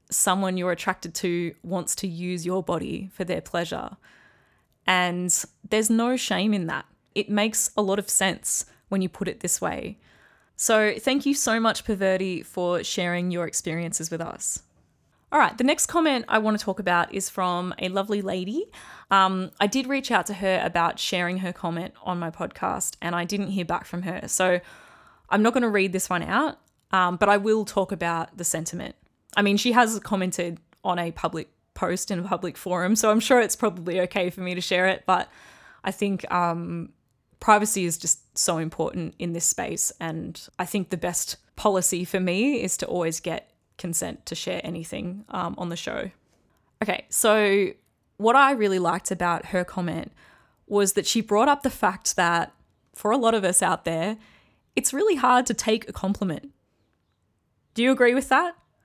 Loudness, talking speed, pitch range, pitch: -24 LUFS, 190 wpm, 175-215 Hz, 190 Hz